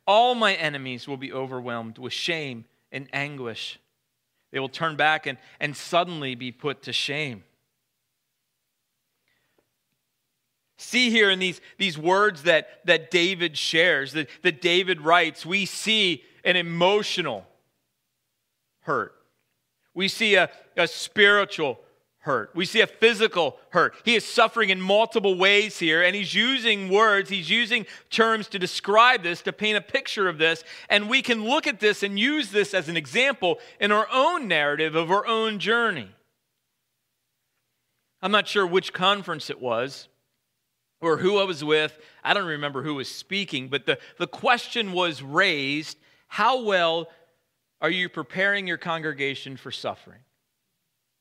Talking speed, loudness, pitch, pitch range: 150 wpm, -23 LUFS, 180 Hz, 145-205 Hz